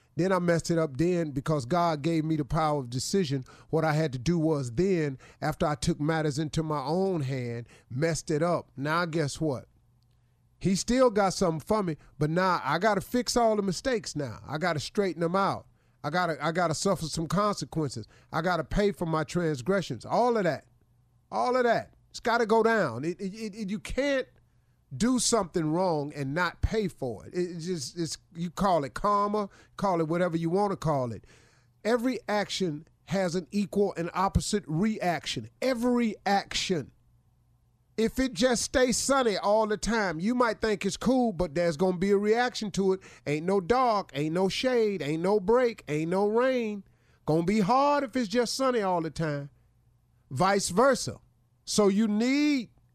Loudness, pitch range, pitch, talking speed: -28 LUFS, 145-210 Hz, 175 Hz, 195 wpm